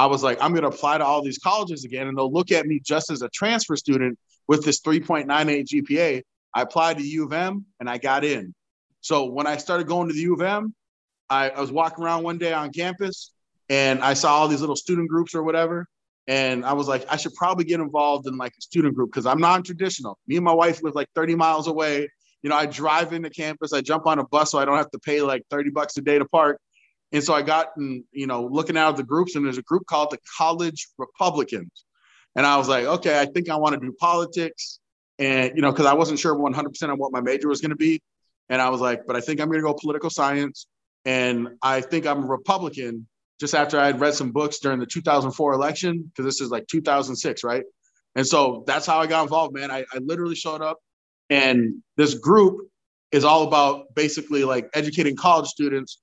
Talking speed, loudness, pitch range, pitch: 240 wpm, -22 LUFS, 135-165 Hz, 150 Hz